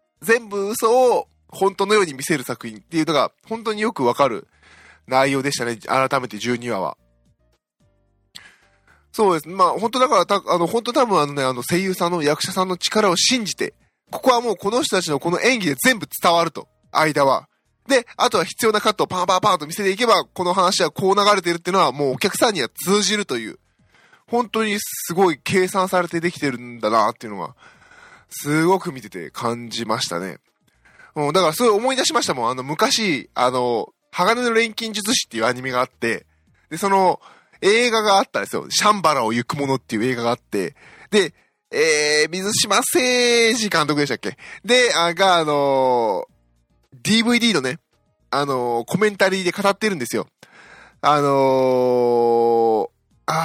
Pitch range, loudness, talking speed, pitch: 135-220 Hz, -19 LUFS, 345 characters per minute, 180 Hz